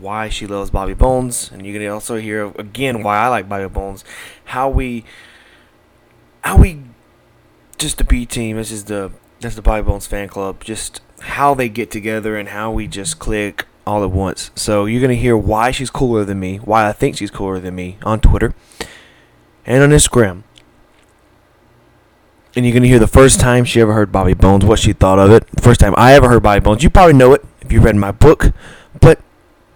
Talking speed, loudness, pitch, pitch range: 205 wpm, -13 LUFS, 105 Hz, 100-120 Hz